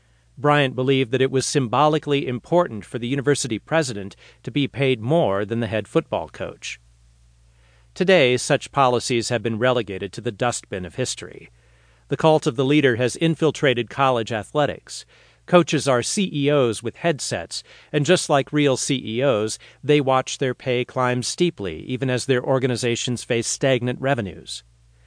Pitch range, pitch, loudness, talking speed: 115-145 Hz, 125 Hz, -21 LUFS, 150 wpm